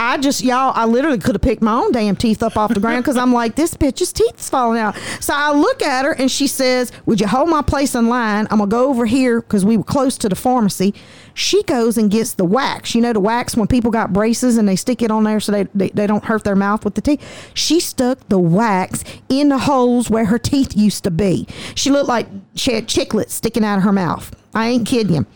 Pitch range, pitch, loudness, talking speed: 210-260 Hz, 235 Hz, -16 LUFS, 265 wpm